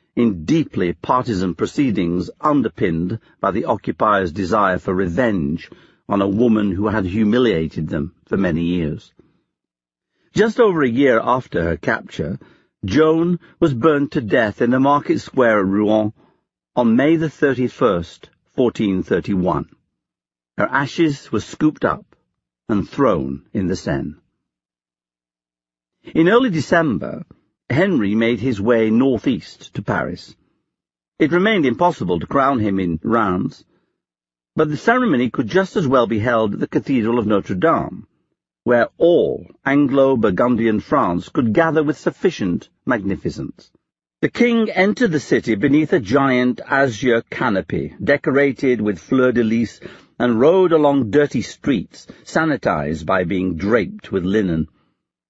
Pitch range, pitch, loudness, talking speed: 90-145 Hz, 120 Hz, -18 LUFS, 130 wpm